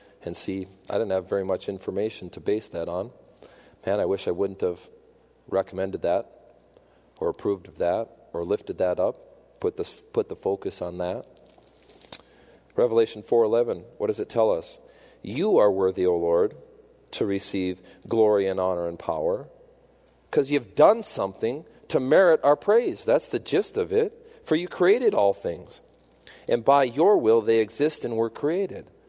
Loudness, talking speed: -25 LUFS, 165 wpm